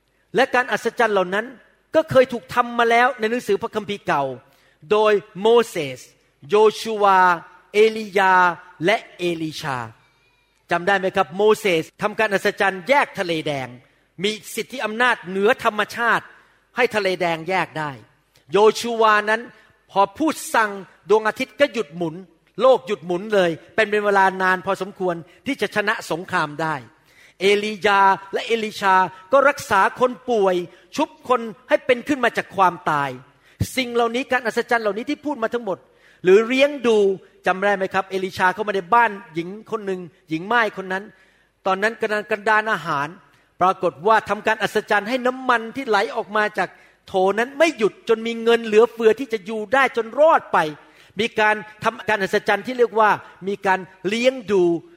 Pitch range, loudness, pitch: 180-230 Hz, -20 LUFS, 205 Hz